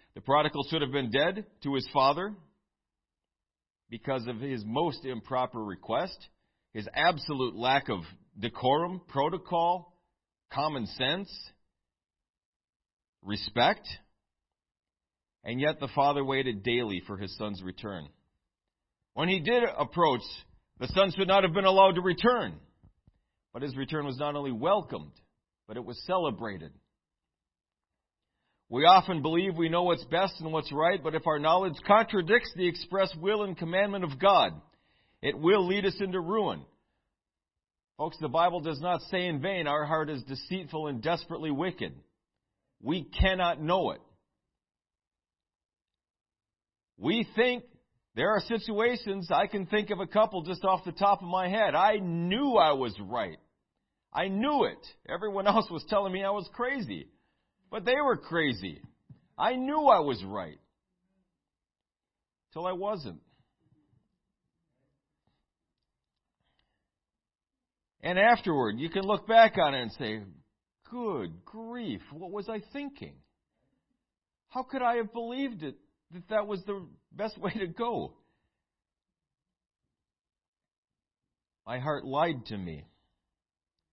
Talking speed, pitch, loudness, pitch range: 135 wpm, 170 Hz, -29 LUFS, 125-200 Hz